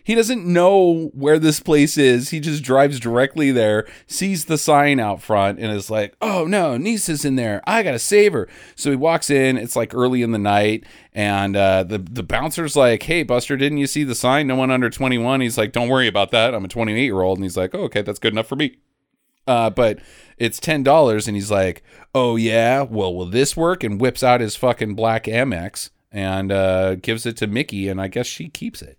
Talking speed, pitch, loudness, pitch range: 230 wpm, 125 Hz, -18 LUFS, 105-145 Hz